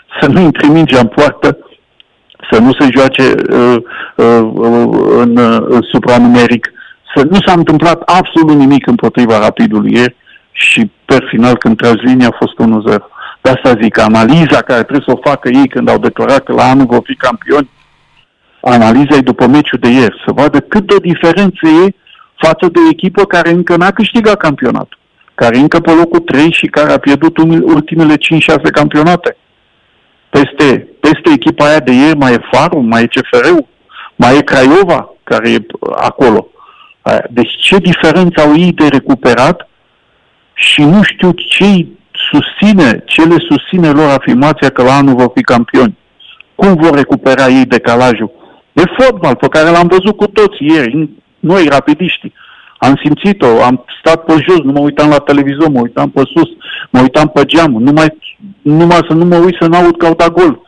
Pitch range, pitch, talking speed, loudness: 130-175 Hz, 155 Hz, 170 wpm, -7 LUFS